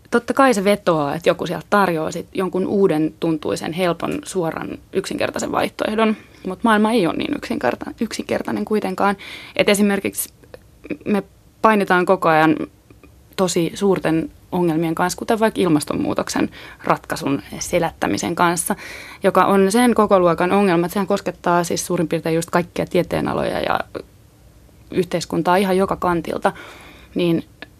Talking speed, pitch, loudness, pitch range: 130 wpm, 185 Hz, -19 LUFS, 170-205 Hz